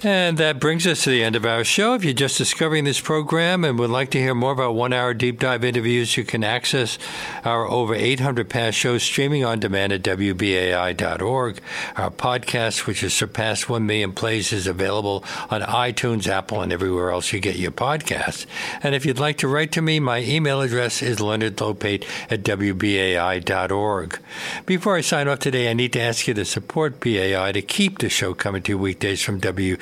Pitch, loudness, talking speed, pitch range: 115 Hz, -21 LUFS, 195 wpm, 100-135 Hz